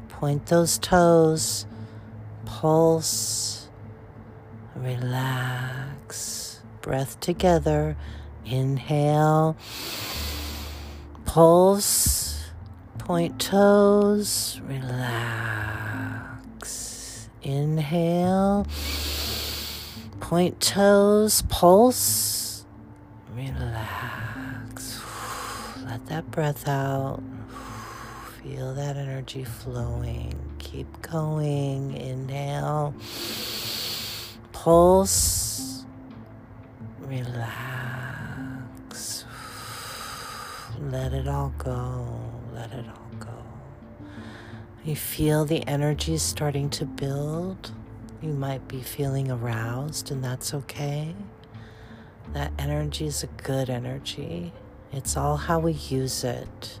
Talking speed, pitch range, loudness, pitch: 70 wpm, 110-140 Hz, -25 LUFS, 120 Hz